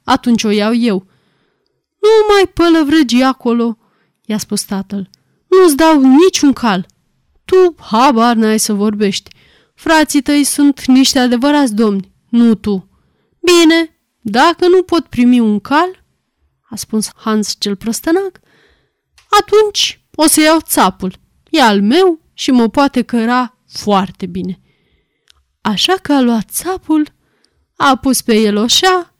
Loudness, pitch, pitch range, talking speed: -12 LUFS, 255 Hz, 215-320 Hz, 130 wpm